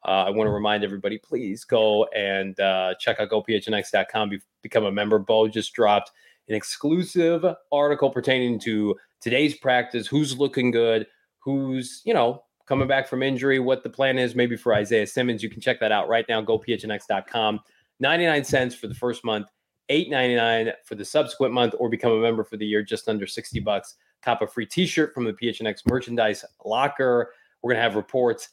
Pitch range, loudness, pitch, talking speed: 110-135 Hz, -23 LUFS, 120 Hz, 190 wpm